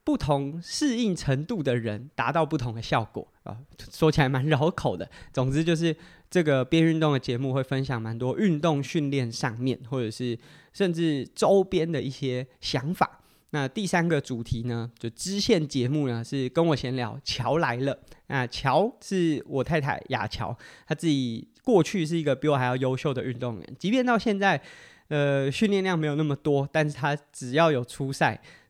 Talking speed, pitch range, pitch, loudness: 265 characters per minute, 130-165 Hz, 145 Hz, -26 LUFS